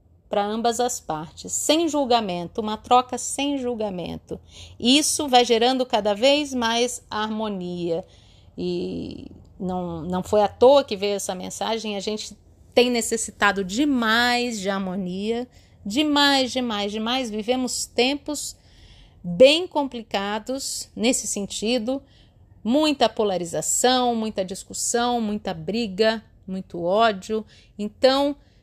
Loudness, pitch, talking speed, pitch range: -22 LUFS, 220 Hz, 110 wpm, 195-250 Hz